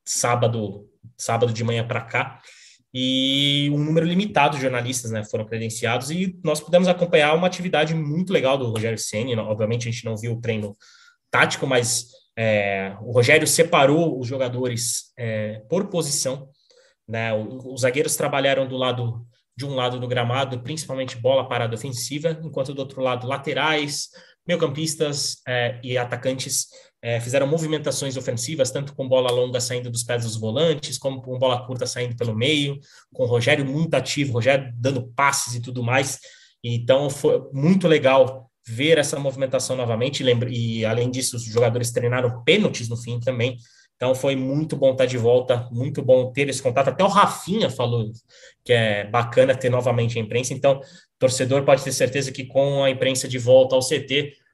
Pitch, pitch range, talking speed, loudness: 130 Hz, 120-145 Hz, 170 wpm, -22 LUFS